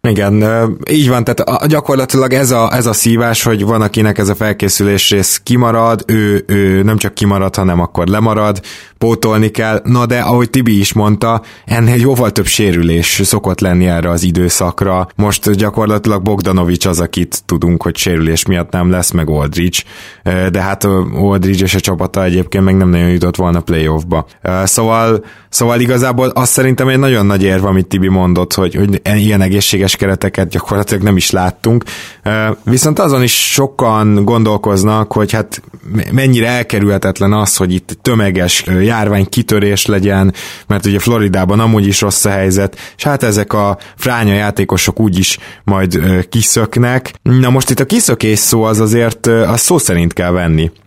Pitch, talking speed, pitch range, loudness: 105 Hz, 165 wpm, 95-115 Hz, -11 LUFS